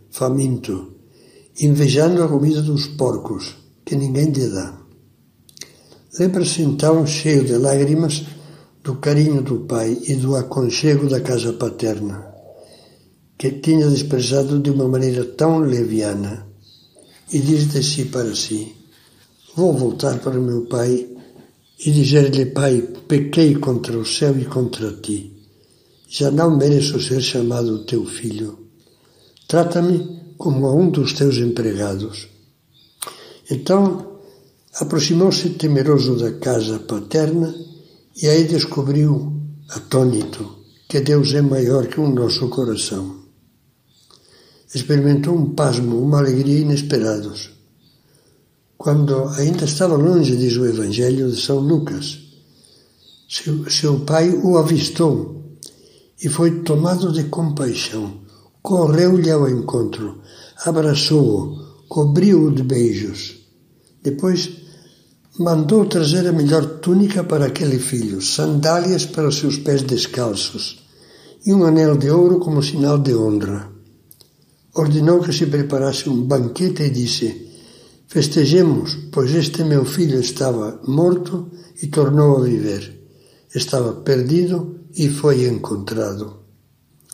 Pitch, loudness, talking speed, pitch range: 140 Hz, -17 LUFS, 115 wpm, 120-155 Hz